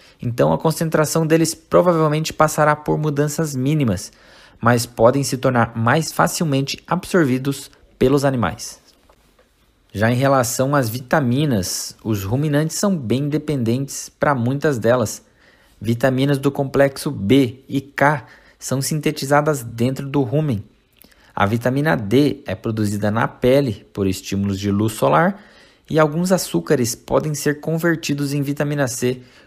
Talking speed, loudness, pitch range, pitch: 130 wpm, -19 LUFS, 120-150 Hz, 135 Hz